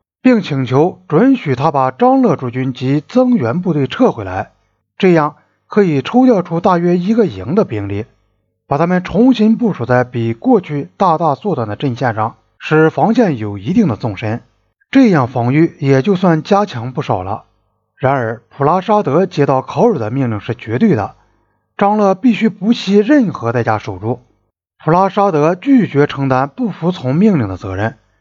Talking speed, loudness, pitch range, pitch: 255 characters per minute, -14 LUFS, 120-200 Hz, 150 Hz